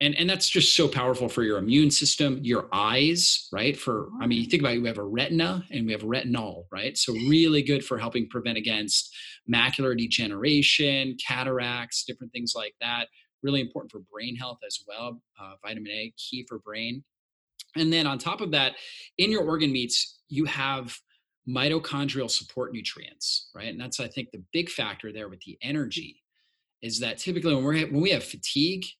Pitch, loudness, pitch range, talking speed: 130 Hz, -25 LUFS, 120-150 Hz, 190 wpm